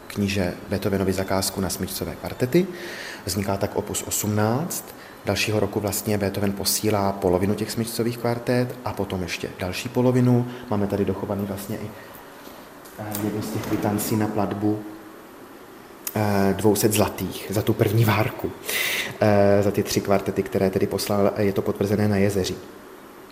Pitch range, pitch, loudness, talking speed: 100-110 Hz, 105 Hz, -24 LUFS, 135 wpm